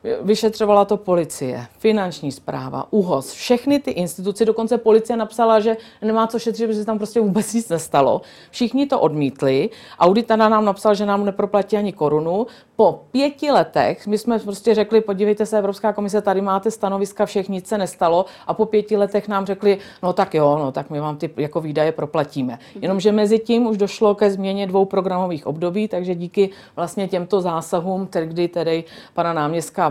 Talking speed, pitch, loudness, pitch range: 175 wpm, 200 Hz, -19 LUFS, 175-220 Hz